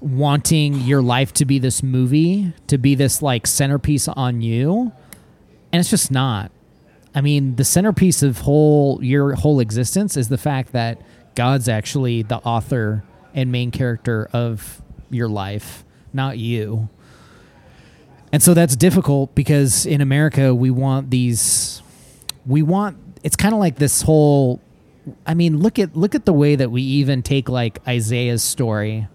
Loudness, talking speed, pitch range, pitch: -17 LUFS, 155 wpm, 120-150 Hz, 135 Hz